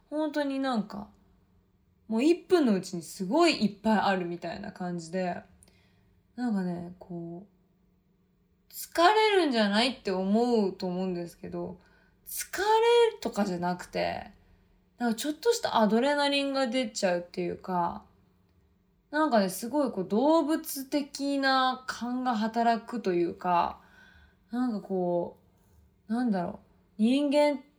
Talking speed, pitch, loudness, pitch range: 270 characters per minute, 215 Hz, -28 LUFS, 175-270 Hz